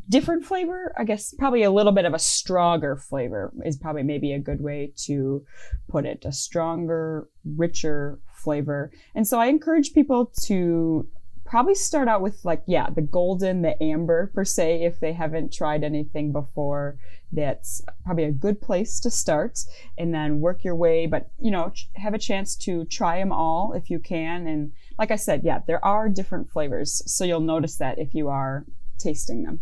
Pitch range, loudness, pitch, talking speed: 150-195 Hz, -24 LUFS, 165 Hz, 190 wpm